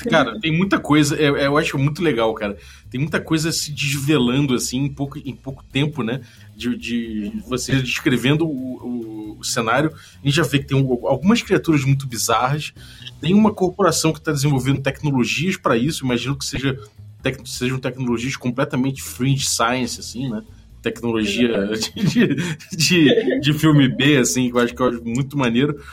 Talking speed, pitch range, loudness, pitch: 170 wpm, 120-150 Hz, -19 LUFS, 135 Hz